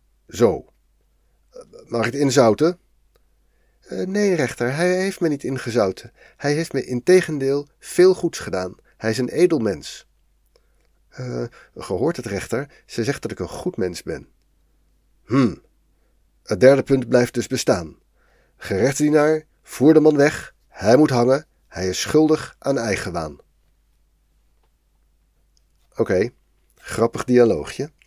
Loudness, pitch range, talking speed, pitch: -20 LUFS, 115-155 Hz, 135 wpm, 135 Hz